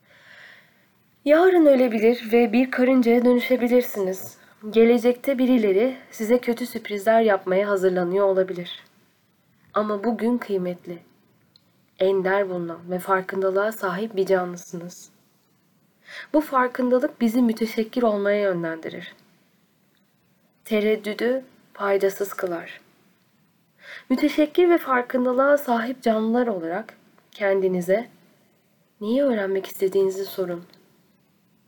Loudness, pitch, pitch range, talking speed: -22 LUFS, 205 Hz, 190-245 Hz, 85 wpm